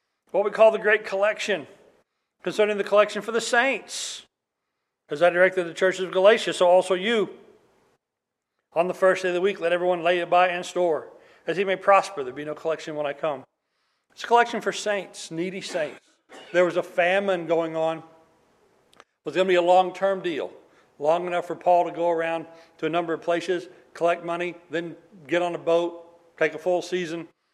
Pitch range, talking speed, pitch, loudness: 170-195 Hz, 200 wpm, 180 Hz, -24 LUFS